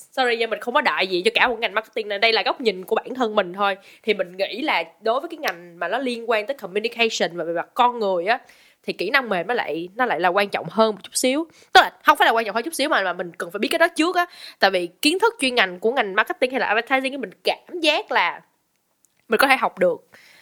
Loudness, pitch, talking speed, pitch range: -21 LUFS, 235 Hz, 285 wpm, 205-300 Hz